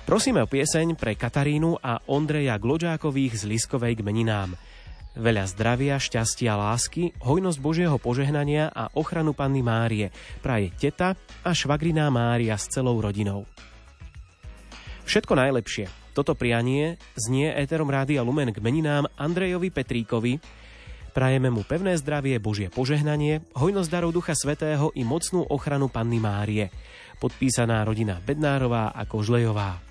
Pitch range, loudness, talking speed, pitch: 115-150 Hz, -25 LUFS, 125 wpm, 130 Hz